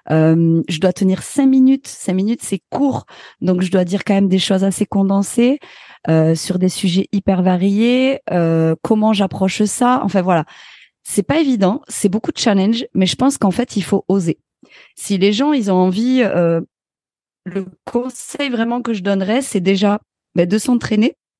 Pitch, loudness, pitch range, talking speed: 200 Hz, -16 LUFS, 185-240 Hz, 180 wpm